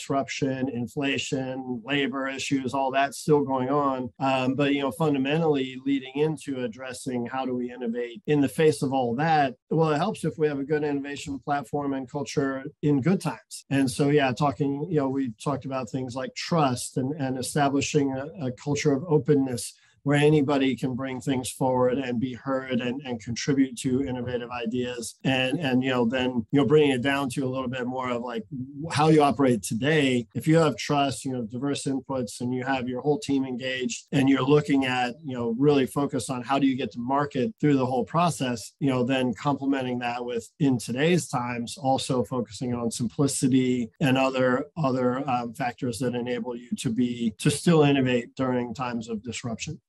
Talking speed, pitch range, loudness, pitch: 190 wpm, 125-145 Hz, -26 LUFS, 135 Hz